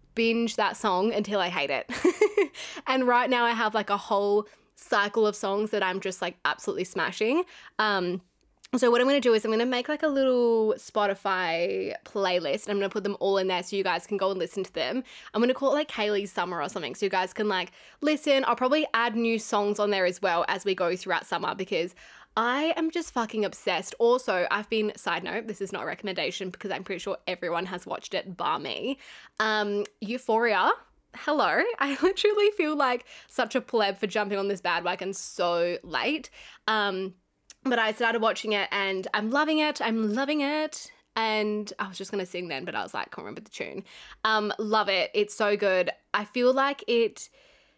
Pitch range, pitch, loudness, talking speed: 195-245 Hz, 215 Hz, -27 LUFS, 215 wpm